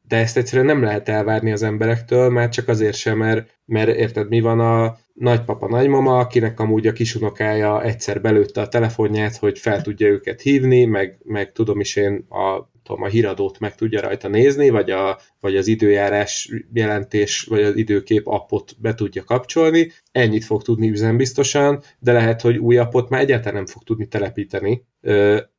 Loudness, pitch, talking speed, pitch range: -18 LUFS, 110 Hz, 175 wpm, 105-120 Hz